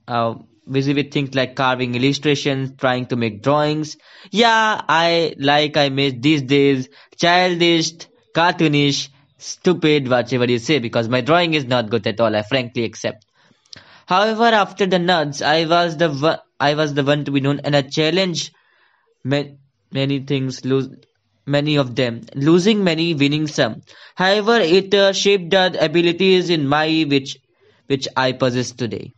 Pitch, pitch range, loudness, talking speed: 145 Hz, 135-170 Hz, -17 LUFS, 155 wpm